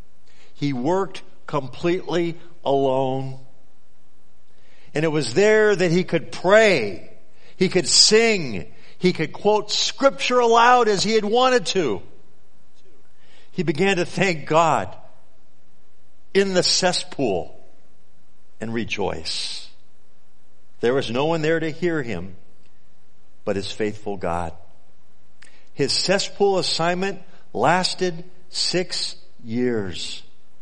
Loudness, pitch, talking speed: -20 LUFS, 160 Hz, 105 wpm